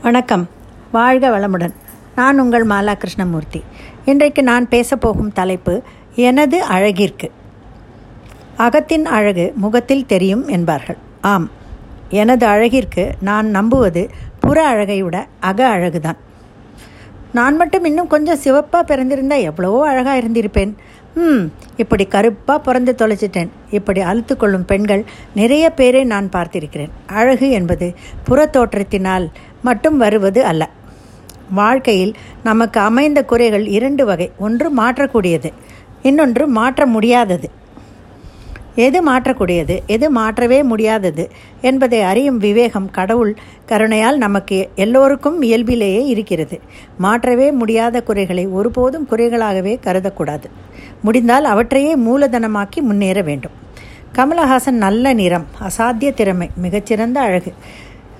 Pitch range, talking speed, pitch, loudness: 185-255 Hz, 105 wpm, 220 Hz, -14 LUFS